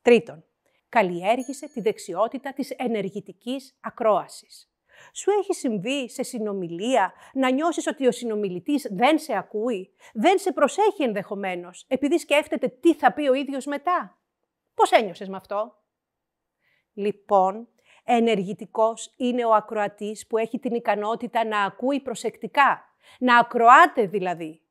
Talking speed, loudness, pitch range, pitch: 125 wpm, -23 LUFS, 210-275 Hz, 235 Hz